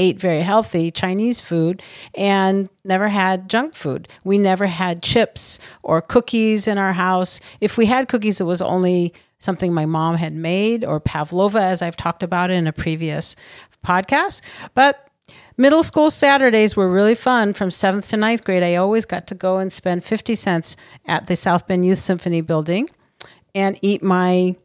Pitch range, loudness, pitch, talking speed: 175-215 Hz, -18 LUFS, 190 Hz, 175 wpm